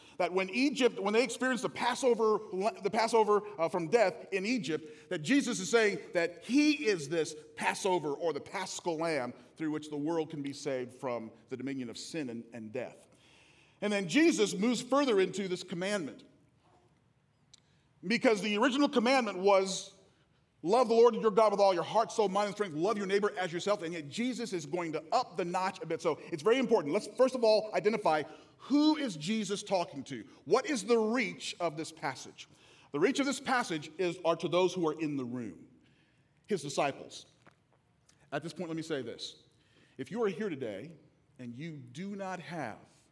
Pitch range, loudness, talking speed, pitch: 155-225 Hz, -32 LUFS, 190 wpm, 190 Hz